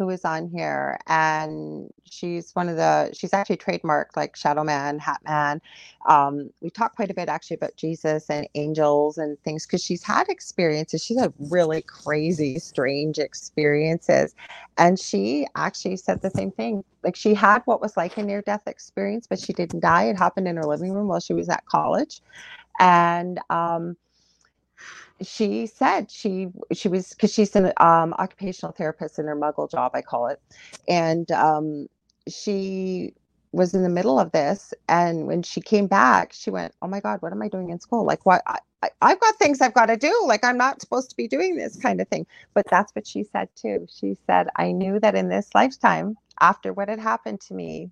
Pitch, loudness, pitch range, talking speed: 180 Hz, -23 LUFS, 155-205 Hz, 195 wpm